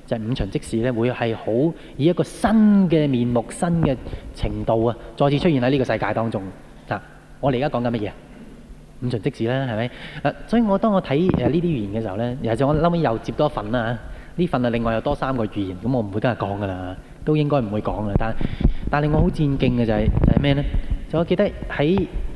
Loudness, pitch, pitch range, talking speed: -22 LUFS, 125 Hz, 115-150 Hz, 325 characters per minute